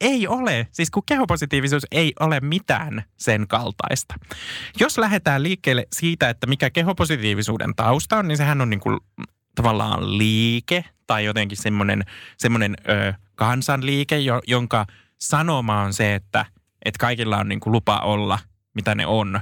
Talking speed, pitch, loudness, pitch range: 140 wpm, 120 Hz, -21 LUFS, 105-150 Hz